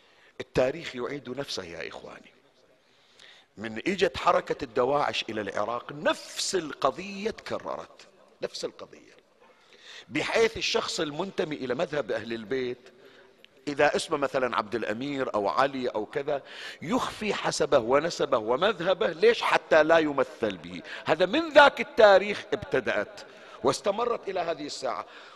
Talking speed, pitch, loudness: 120 wpm, 195 Hz, -27 LUFS